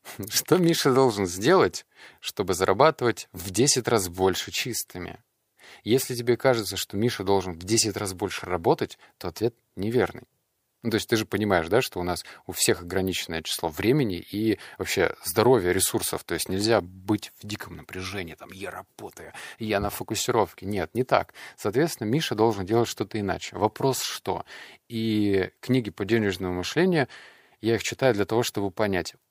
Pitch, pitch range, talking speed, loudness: 105 Hz, 95-120 Hz, 165 wpm, -25 LUFS